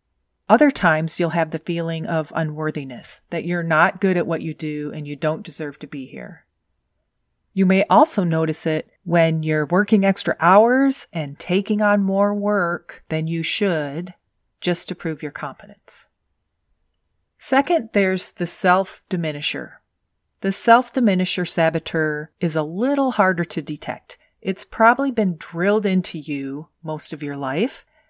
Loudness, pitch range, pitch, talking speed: -20 LUFS, 155-195 Hz, 170 Hz, 150 wpm